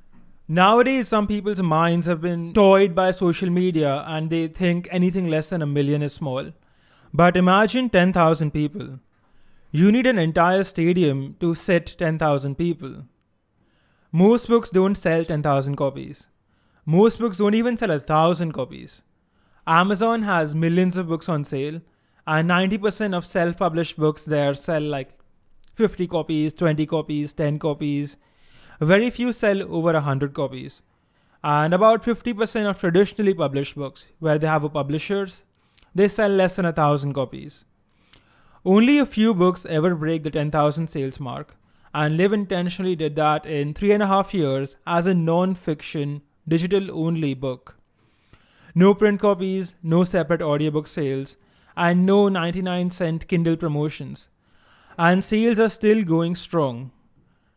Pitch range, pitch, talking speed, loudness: 150-190 Hz, 170 Hz, 145 wpm, -21 LUFS